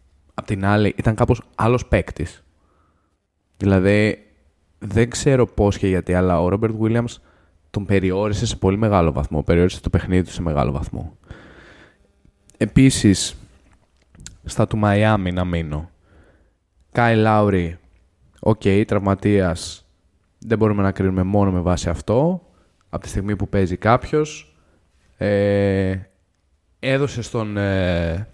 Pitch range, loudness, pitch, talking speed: 85-105 Hz, -19 LUFS, 95 Hz, 120 wpm